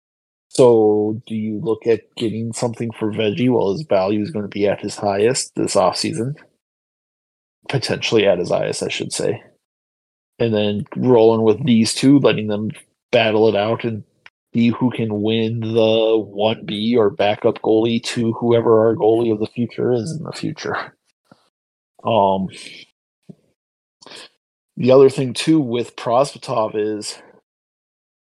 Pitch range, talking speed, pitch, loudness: 105-115 Hz, 145 wpm, 110 Hz, -18 LUFS